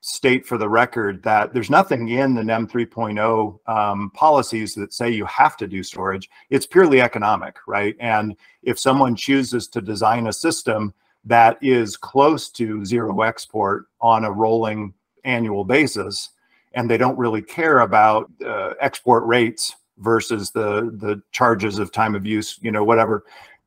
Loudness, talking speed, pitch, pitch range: -19 LUFS, 160 wpm, 115 Hz, 105-120 Hz